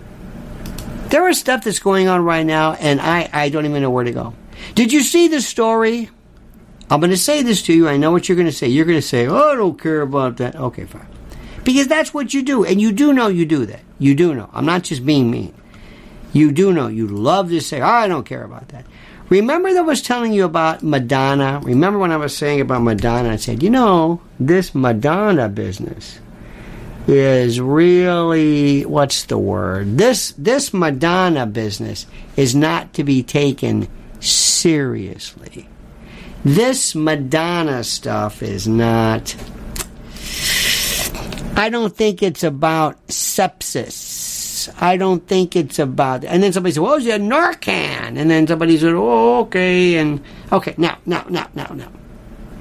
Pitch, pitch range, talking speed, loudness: 160 Hz, 140-195 Hz, 180 wpm, -16 LUFS